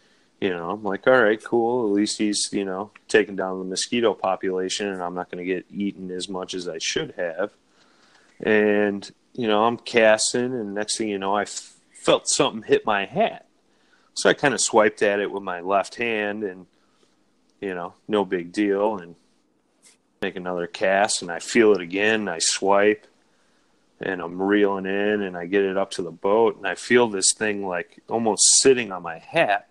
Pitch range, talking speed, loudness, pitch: 95-105 Hz, 200 wpm, -22 LUFS, 100 Hz